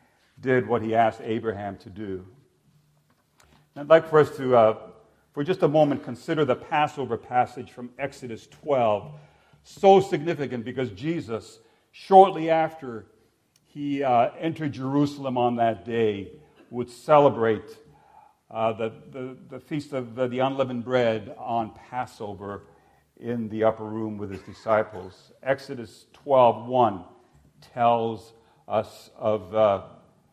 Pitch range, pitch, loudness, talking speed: 110-140 Hz, 120 Hz, -24 LUFS, 130 wpm